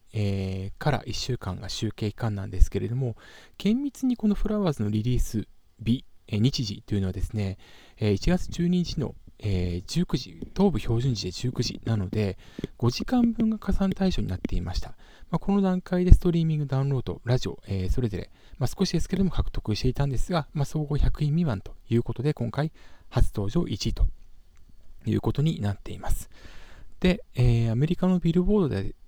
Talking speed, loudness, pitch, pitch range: 325 characters per minute, -27 LUFS, 115 Hz, 100-165 Hz